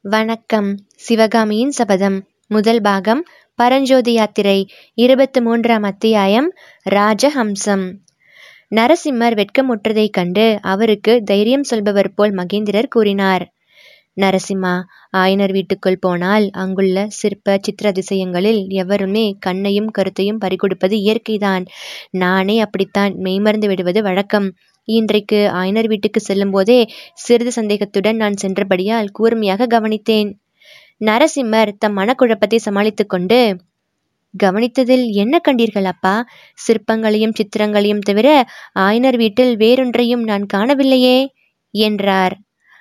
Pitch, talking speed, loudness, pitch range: 210 Hz, 95 wpm, -15 LUFS, 195-230 Hz